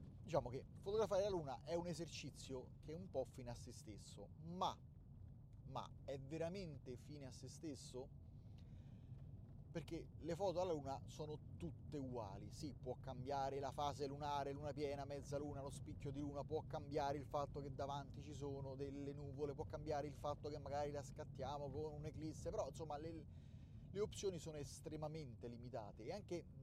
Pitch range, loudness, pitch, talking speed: 130-150 Hz, -49 LUFS, 140 Hz, 170 wpm